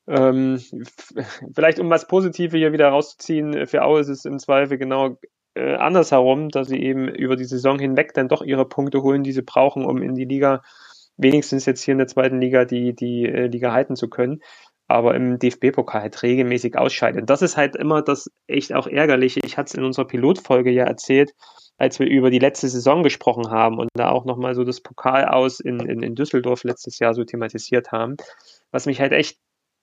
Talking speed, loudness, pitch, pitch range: 195 wpm, -19 LUFS, 130 Hz, 125-140 Hz